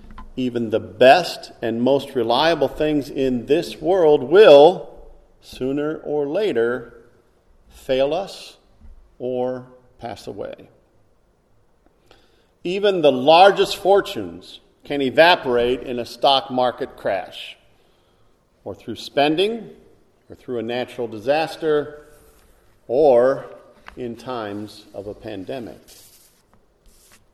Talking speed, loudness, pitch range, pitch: 95 wpm, -18 LUFS, 120-150 Hz, 125 Hz